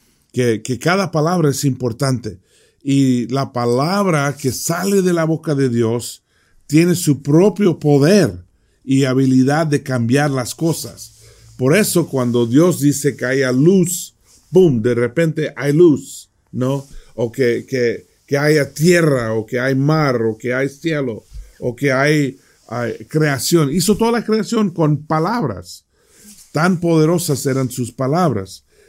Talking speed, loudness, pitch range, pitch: 145 wpm, -16 LUFS, 125-165 Hz, 140 Hz